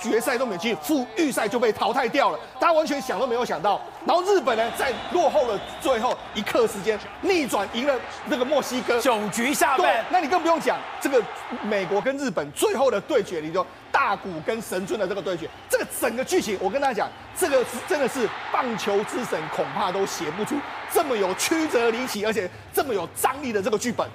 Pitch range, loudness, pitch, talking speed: 225-335 Hz, -24 LUFS, 265 Hz, 315 characters per minute